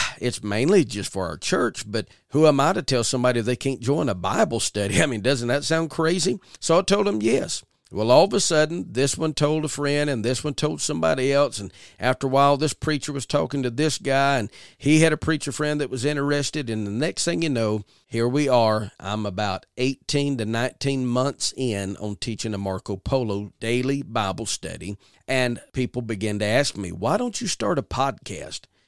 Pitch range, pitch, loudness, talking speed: 110-145 Hz, 130 Hz, -23 LUFS, 210 wpm